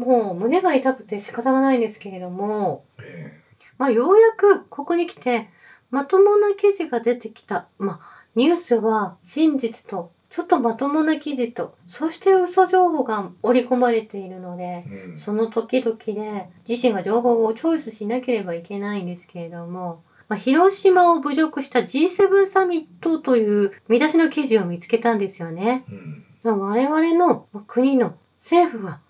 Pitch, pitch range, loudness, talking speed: 235 Hz, 205-315 Hz, -20 LUFS, 310 characters per minute